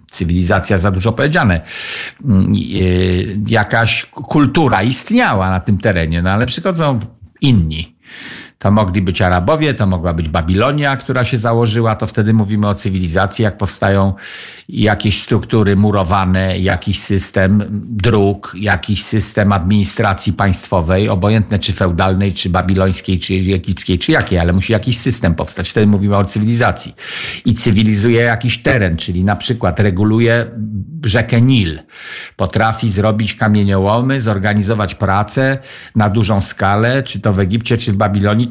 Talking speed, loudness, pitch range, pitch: 135 wpm, -14 LUFS, 95-115 Hz, 105 Hz